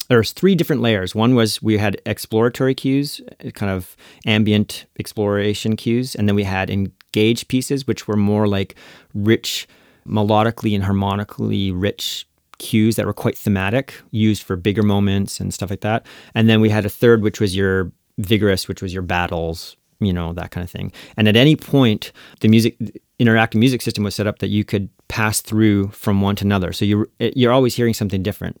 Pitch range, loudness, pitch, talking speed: 100-115 Hz, -18 LUFS, 105 Hz, 195 wpm